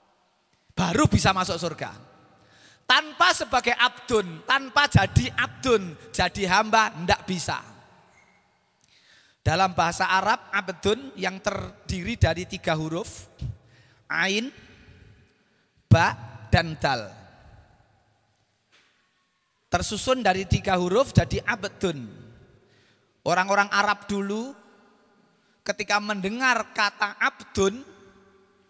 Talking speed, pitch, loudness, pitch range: 85 wpm, 195 Hz, -24 LUFS, 170-210 Hz